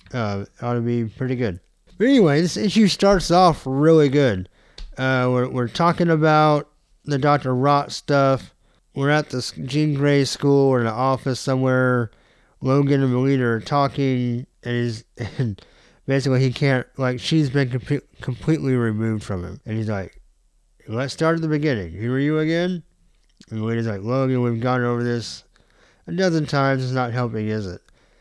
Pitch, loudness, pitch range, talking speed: 130 Hz, -21 LUFS, 120-145 Hz, 175 wpm